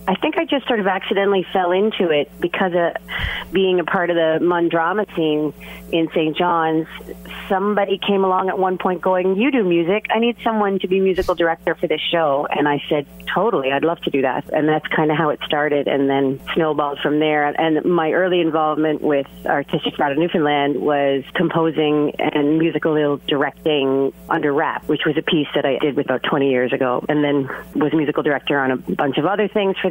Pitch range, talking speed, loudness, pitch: 150-185 Hz, 205 wpm, -19 LUFS, 160 Hz